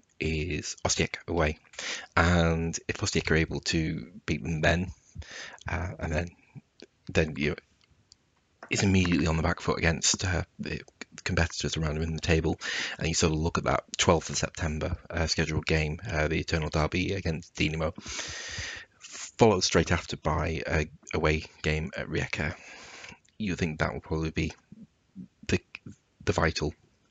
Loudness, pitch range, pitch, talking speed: -29 LUFS, 80-85 Hz, 80 Hz, 155 wpm